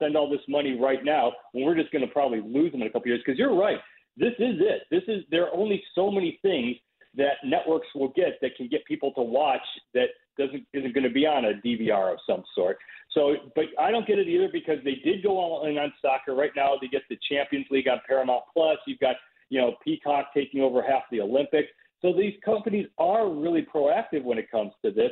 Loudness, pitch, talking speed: -26 LUFS, 155 Hz, 240 wpm